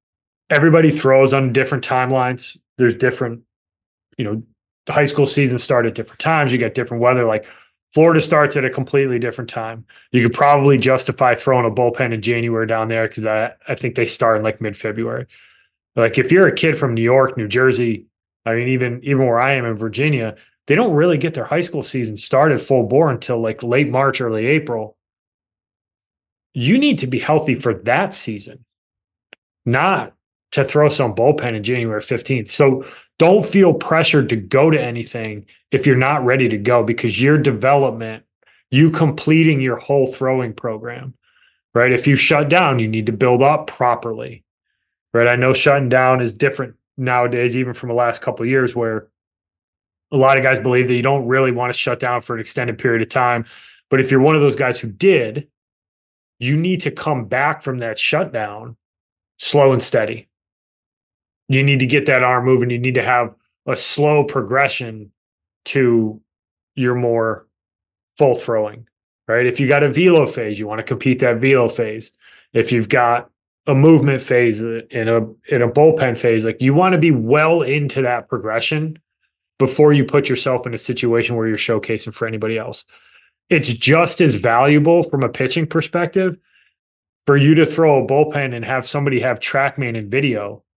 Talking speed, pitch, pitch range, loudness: 185 wpm, 125 Hz, 115-140 Hz, -16 LUFS